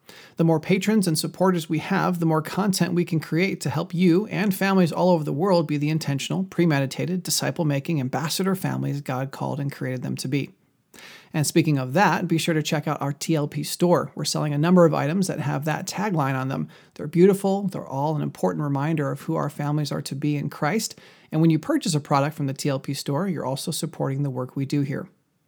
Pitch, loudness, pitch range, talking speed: 160 Hz, -24 LUFS, 145-175 Hz, 225 wpm